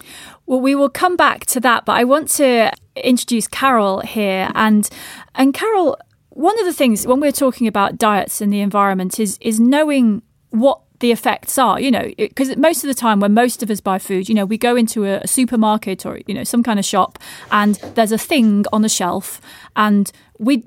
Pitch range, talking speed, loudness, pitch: 210-265 Hz, 210 wpm, -16 LUFS, 230 Hz